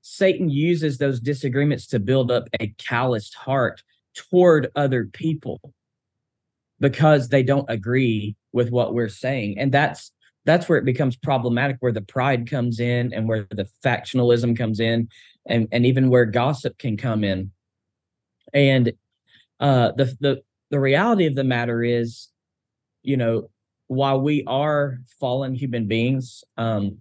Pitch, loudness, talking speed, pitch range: 125 Hz, -21 LUFS, 145 wpm, 115-140 Hz